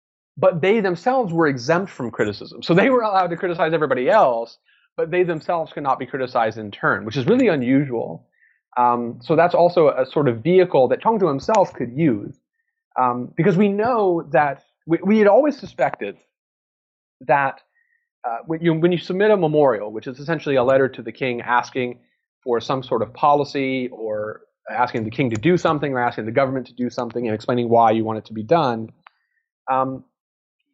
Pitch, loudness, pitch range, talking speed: 140 Hz, -20 LUFS, 120-175 Hz, 190 wpm